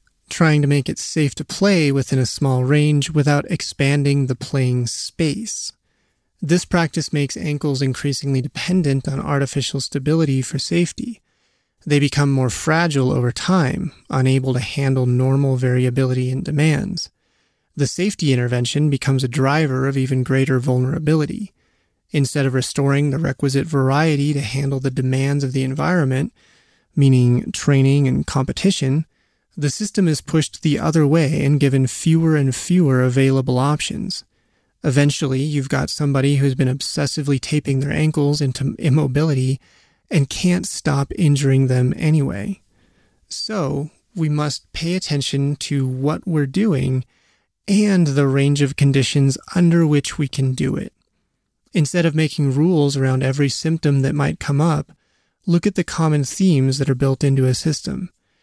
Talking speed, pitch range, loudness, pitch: 145 wpm, 135-155 Hz, -19 LUFS, 140 Hz